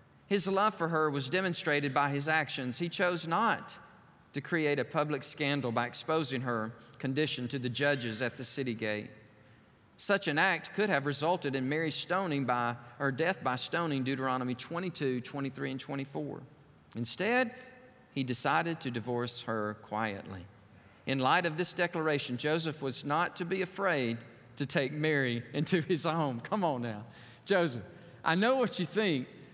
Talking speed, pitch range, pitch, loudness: 165 wpm, 125-170 Hz, 145 Hz, -32 LUFS